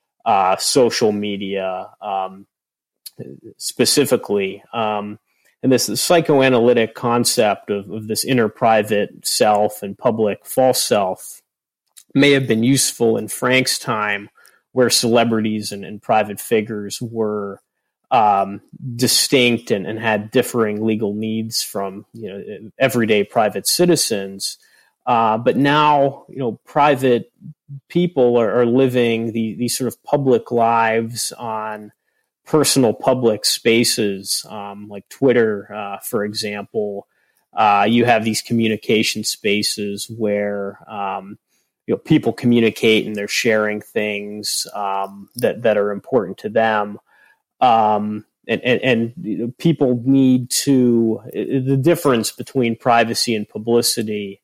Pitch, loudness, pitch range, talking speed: 115 Hz, -18 LUFS, 105-125 Hz, 120 wpm